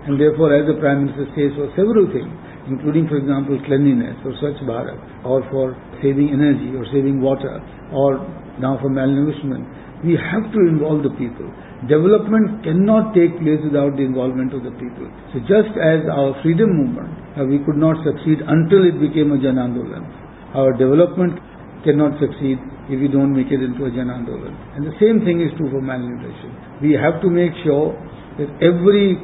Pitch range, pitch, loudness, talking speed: 135-160 Hz, 145 Hz, -17 LUFS, 180 wpm